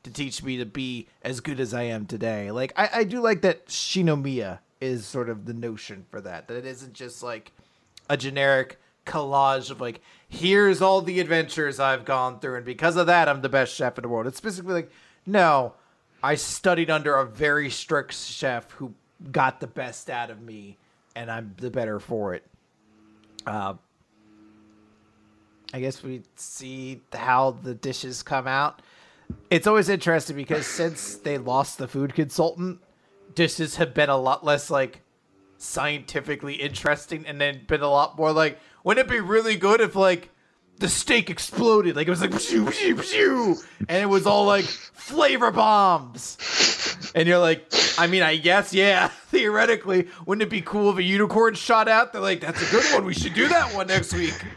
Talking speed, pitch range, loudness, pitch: 180 wpm, 125-180 Hz, -23 LUFS, 145 Hz